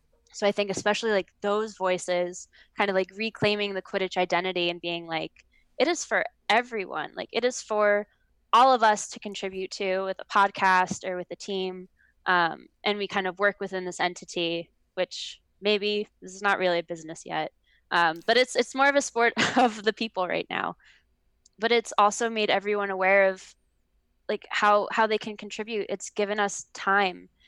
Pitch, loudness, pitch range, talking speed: 200 Hz, -26 LUFS, 185-215 Hz, 190 wpm